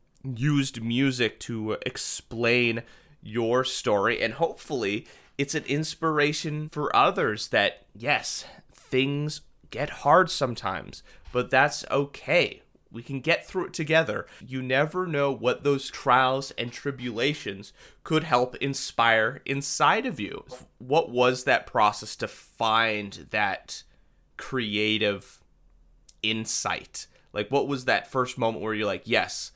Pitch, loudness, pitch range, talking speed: 130 Hz, -26 LUFS, 115-145 Hz, 125 wpm